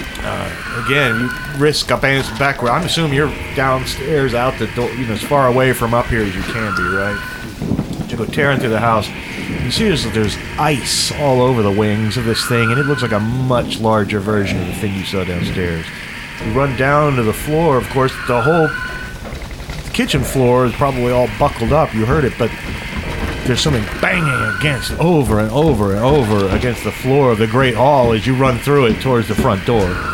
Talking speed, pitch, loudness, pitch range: 210 wpm, 120 Hz, -16 LUFS, 110-135 Hz